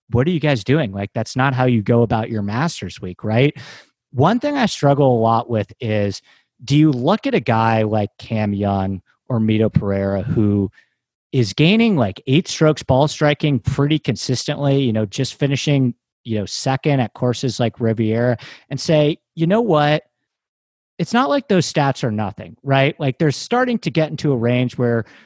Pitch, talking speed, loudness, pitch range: 130 Hz, 190 wpm, -18 LUFS, 110-150 Hz